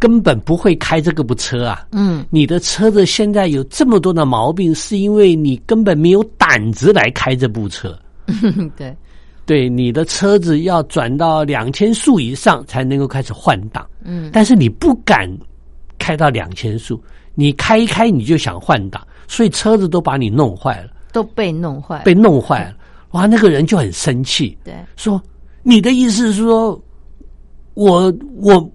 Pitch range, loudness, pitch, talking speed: 135-210 Hz, -13 LUFS, 165 Hz, 240 characters per minute